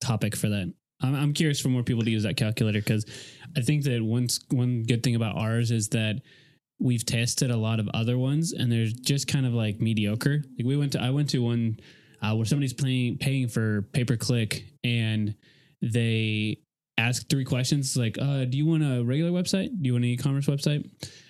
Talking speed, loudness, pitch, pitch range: 210 wpm, -26 LUFS, 125 Hz, 115-140 Hz